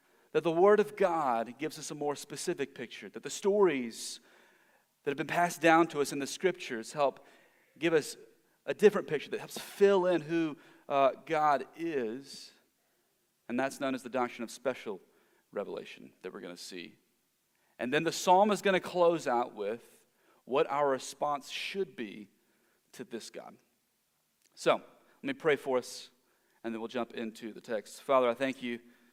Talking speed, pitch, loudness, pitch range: 180 wpm, 145 Hz, -31 LUFS, 125-180 Hz